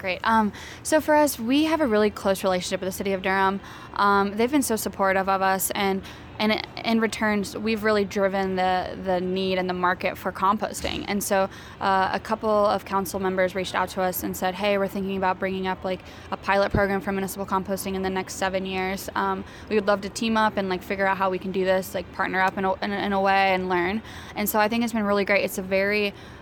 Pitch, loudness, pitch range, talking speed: 195 Hz, -24 LUFS, 190-205 Hz, 245 wpm